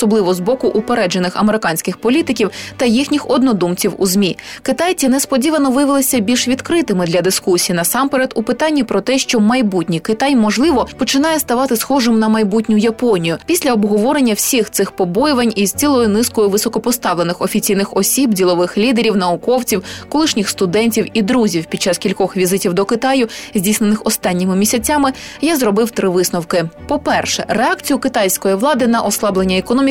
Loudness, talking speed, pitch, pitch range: -14 LUFS, 140 wpm, 225 Hz, 195-260 Hz